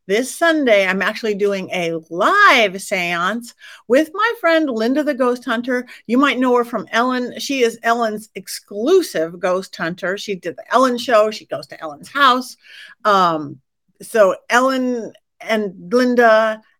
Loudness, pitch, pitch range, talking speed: -17 LUFS, 225 Hz, 195-250 Hz, 150 wpm